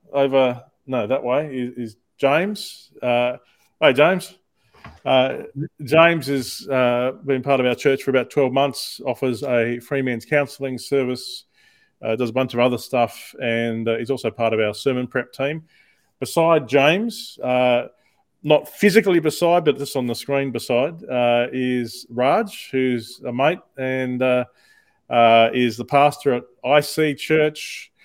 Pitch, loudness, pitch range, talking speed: 130 Hz, -20 LUFS, 125-145 Hz, 160 wpm